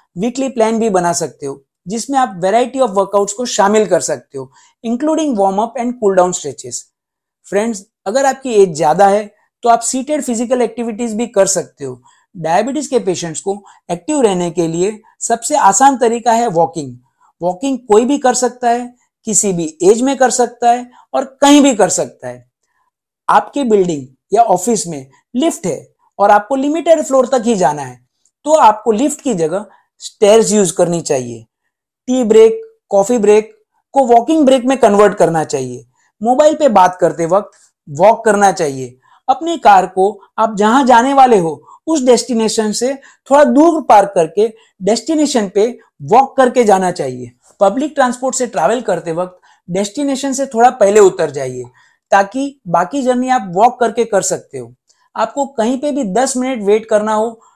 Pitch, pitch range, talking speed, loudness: 225 Hz, 185-260 Hz, 160 wpm, -13 LUFS